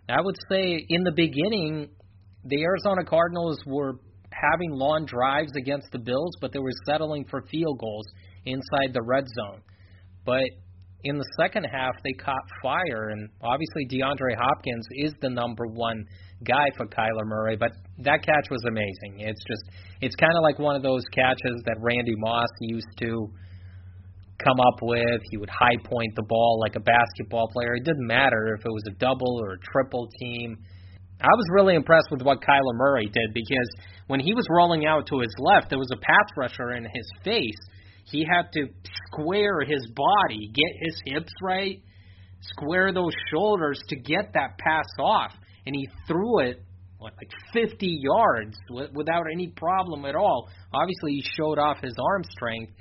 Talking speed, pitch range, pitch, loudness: 175 wpm, 110-150 Hz, 125 Hz, -25 LUFS